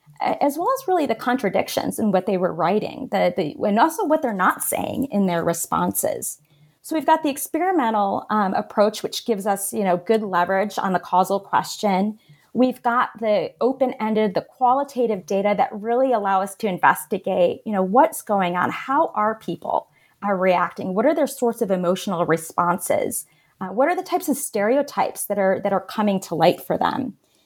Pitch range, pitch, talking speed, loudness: 190-250 Hz, 210 Hz, 190 wpm, -21 LUFS